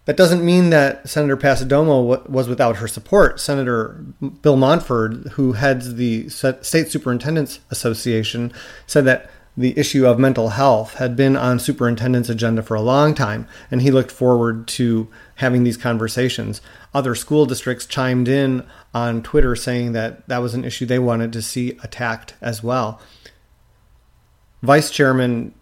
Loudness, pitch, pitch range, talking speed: -18 LUFS, 125 Hz, 115-135 Hz, 150 wpm